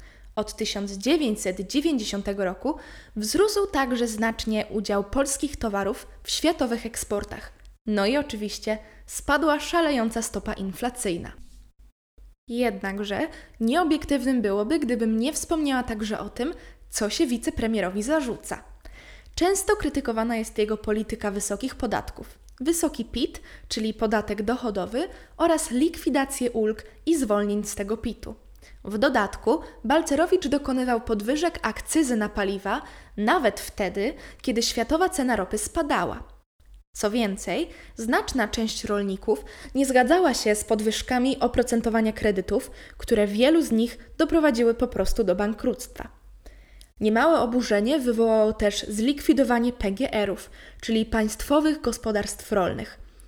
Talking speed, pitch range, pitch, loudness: 110 wpm, 215-285 Hz, 235 Hz, -25 LUFS